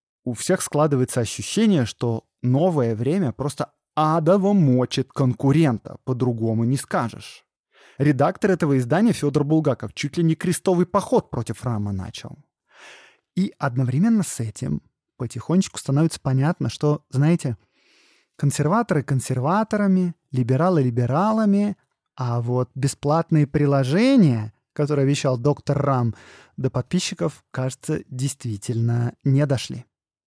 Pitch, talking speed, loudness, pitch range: 140 Hz, 105 wpm, -22 LUFS, 125-165 Hz